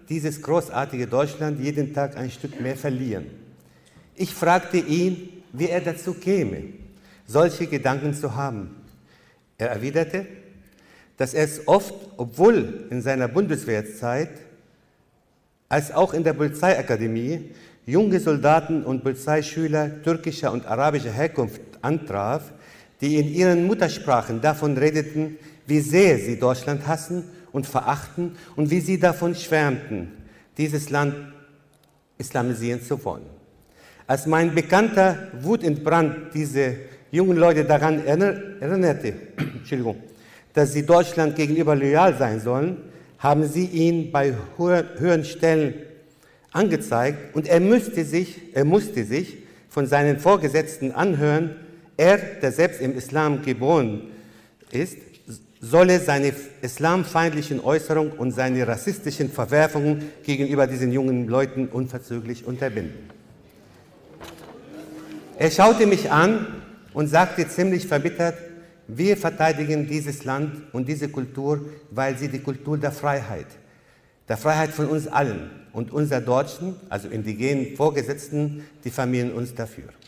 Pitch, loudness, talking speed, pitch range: 150 Hz, -22 LUFS, 120 wpm, 130-165 Hz